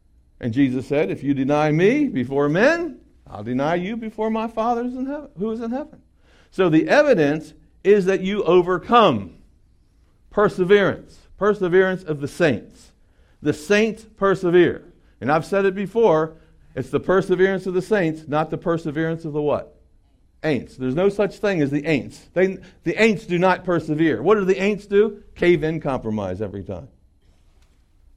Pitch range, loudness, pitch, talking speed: 135-205 Hz, -20 LUFS, 170 Hz, 165 wpm